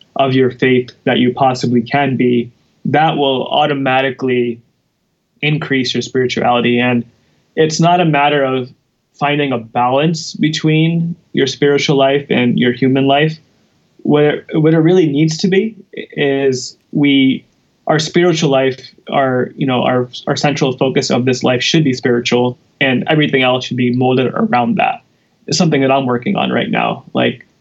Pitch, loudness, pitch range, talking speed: 135 Hz, -14 LUFS, 125-150 Hz, 160 wpm